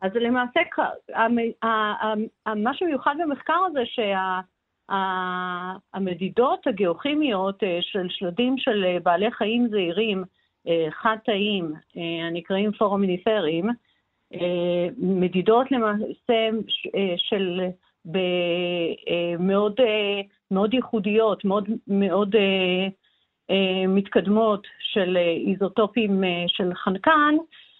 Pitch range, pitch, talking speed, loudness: 185-225 Hz, 200 Hz, 70 wpm, -23 LUFS